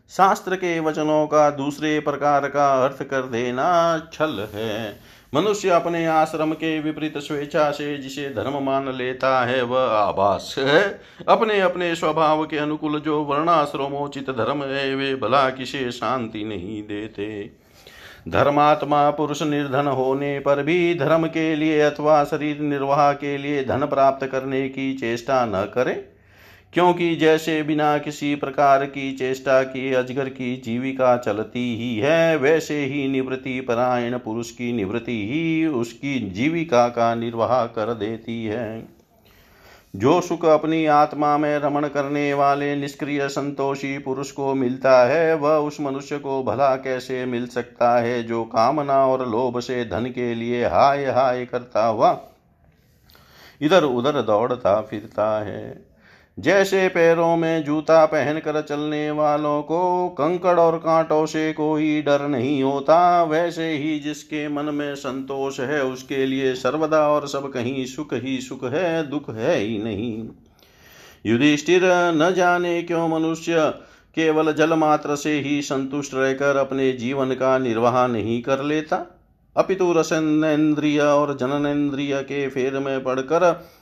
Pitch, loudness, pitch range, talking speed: 140 Hz, -21 LUFS, 130-155 Hz, 140 wpm